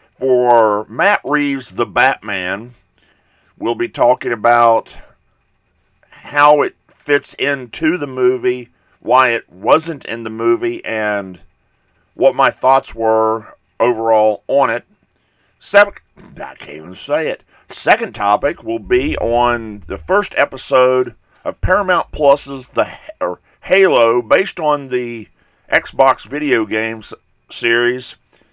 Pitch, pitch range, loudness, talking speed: 120 Hz, 110-145 Hz, -15 LUFS, 115 wpm